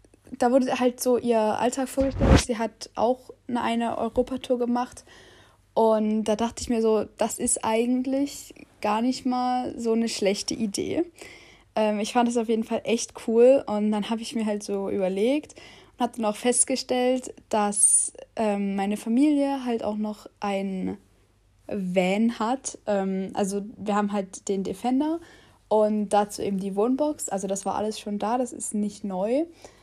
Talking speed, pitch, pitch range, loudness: 170 wpm, 225 Hz, 205-250 Hz, -25 LUFS